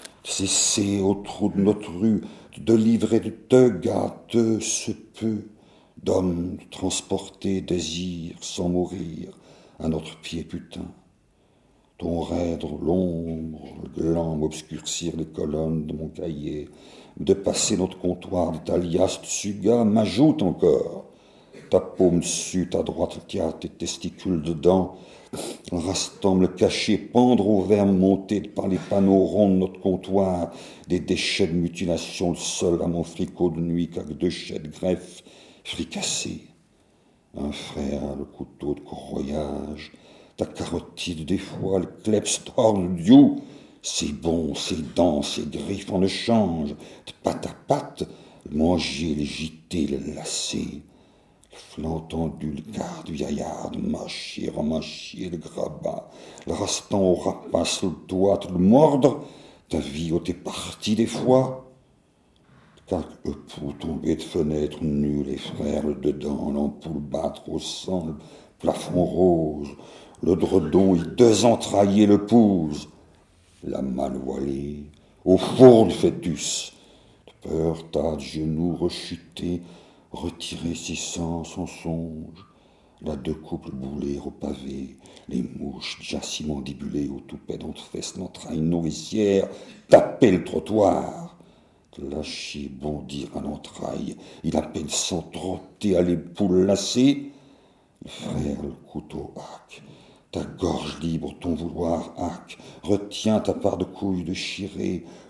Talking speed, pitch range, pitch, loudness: 130 wpm, 80-100 Hz, 85 Hz, -24 LUFS